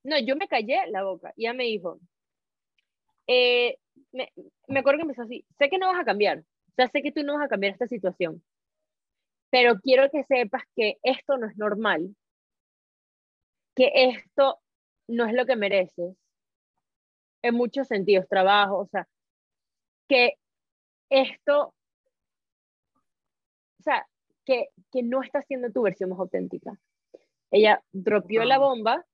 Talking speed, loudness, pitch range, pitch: 150 wpm, -24 LUFS, 205-285 Hz, 255 Hz